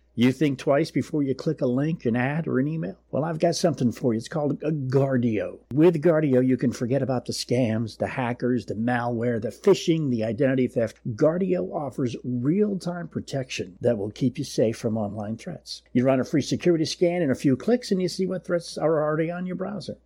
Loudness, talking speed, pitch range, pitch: -25 LUFS, 220 wpm, 125-165 Hz, 135 Hz